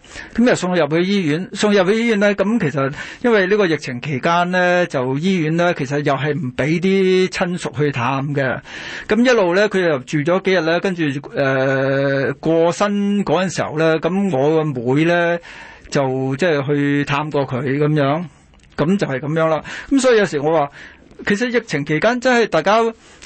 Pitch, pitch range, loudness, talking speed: 160 Hz, 145-195 Hz, -17 LUFS, 270 characters per minute